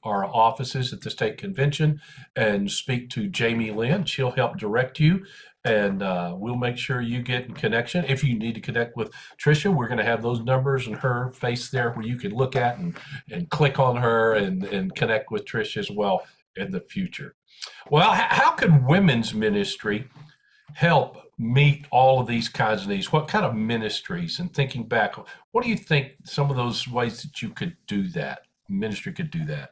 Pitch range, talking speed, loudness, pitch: 115-160 Hz, 200 wpm, -24 LUFS, 130 Hz